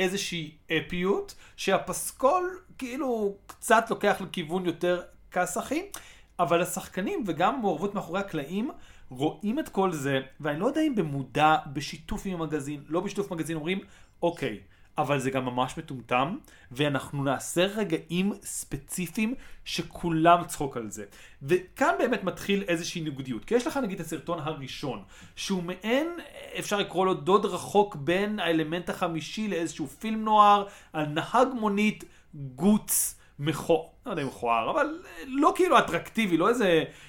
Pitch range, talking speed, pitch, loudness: 155-210 Hz, 135 wpm, 180 Hz, -28 LUFS